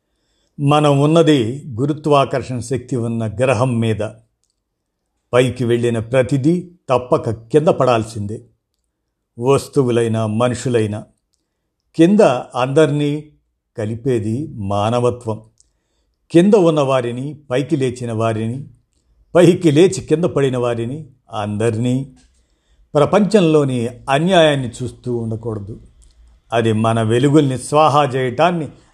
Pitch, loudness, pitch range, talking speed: 125 Hz, -16 LUFS, 115-145 Hz, 80 wpm